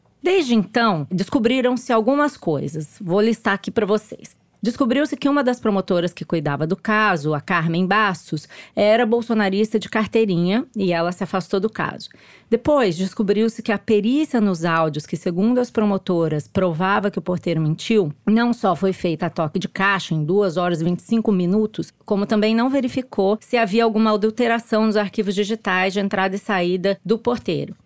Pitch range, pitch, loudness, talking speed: 180-225 Hz, 205 Hz, -20 LUFS, 170 wpm